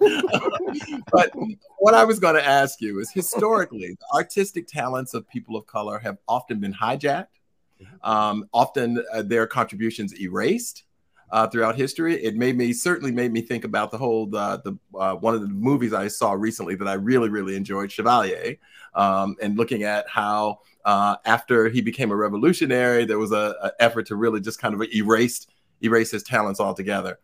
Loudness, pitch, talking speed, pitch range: -22 LUFS, 115 Hz, 180 wpm, 105-125 Hz